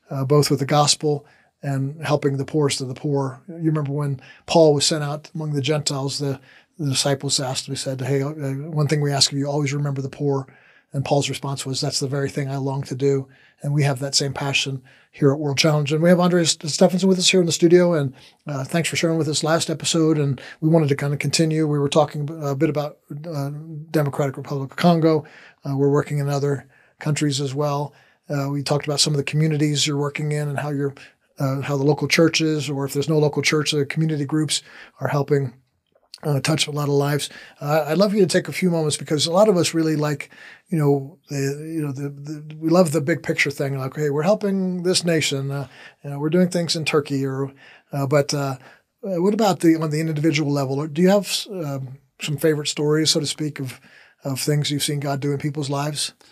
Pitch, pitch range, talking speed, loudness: 145 Hz, 140-155 Hz, 235 wpm, -21 LUFS